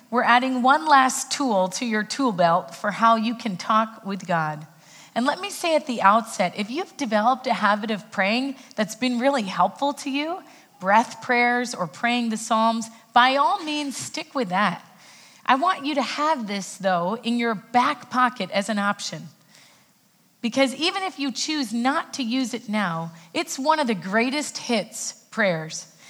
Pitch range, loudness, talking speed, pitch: 205-275 Hz, -23 LUFS, 180 wpm, 235 Hz